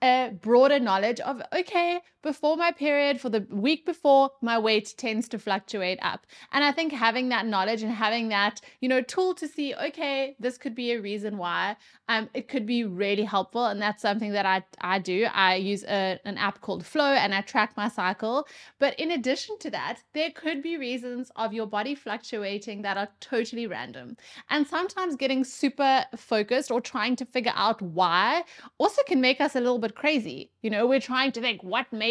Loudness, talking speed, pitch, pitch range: -26 LUFS, 200 wpm, 240 Hz, 210-280 Hz